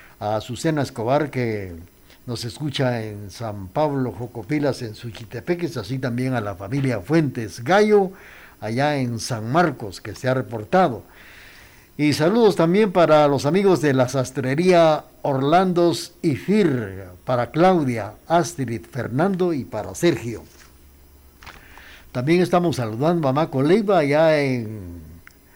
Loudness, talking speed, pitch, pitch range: -21 LUFS, 125 wpm, 130 Hz, 110-160 Hz